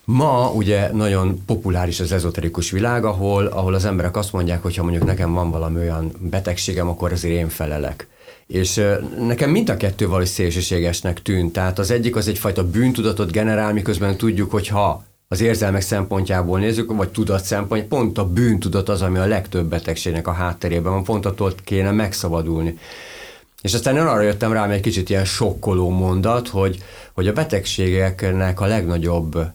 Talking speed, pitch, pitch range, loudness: 165 wpm, 95 Hz, 90-105 Hz, -20 LUFS